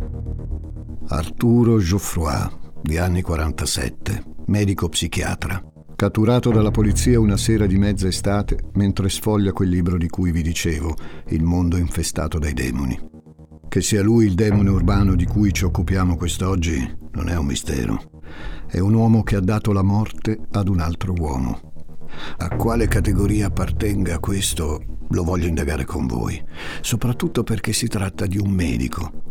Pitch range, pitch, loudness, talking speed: 80-105 Hz, 90 Hz, -21 LUFS, 145 wpm